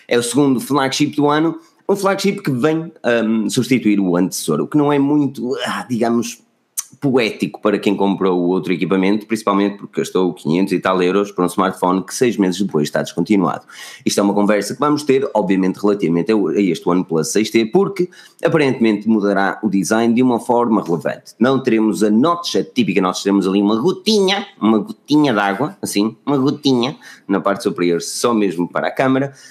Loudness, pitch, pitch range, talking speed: -17 LUFS, 110 Hz, 95-135 Hz, 185 wpm